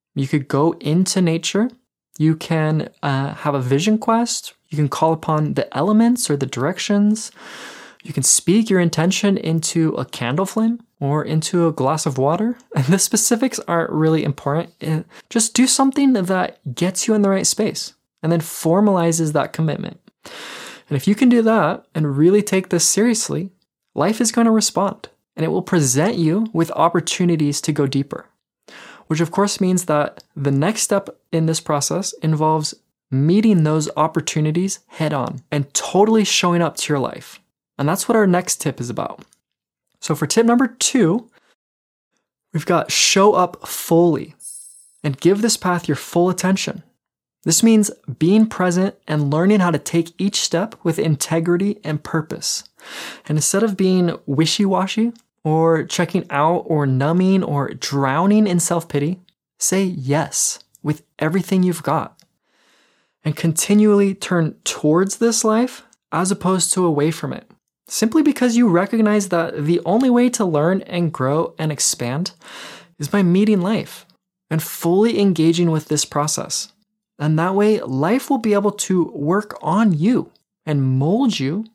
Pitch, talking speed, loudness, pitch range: 175 Hz, 160 wpm, -18 LUFS, 155-205 Hz